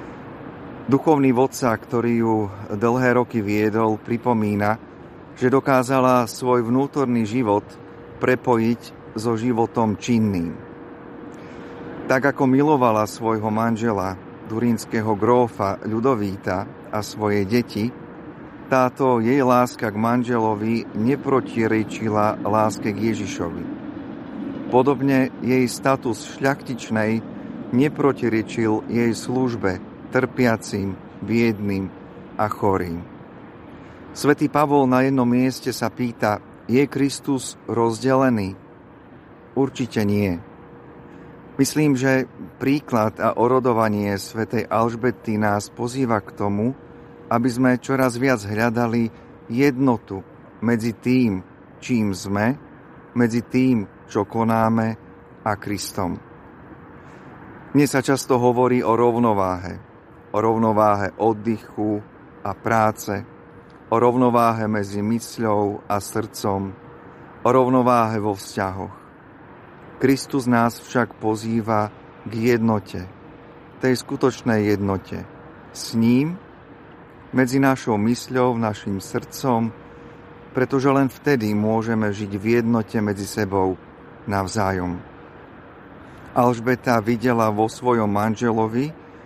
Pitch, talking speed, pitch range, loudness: 115 Hz, 95 wpm, 105-130 Hz, -21 LUFS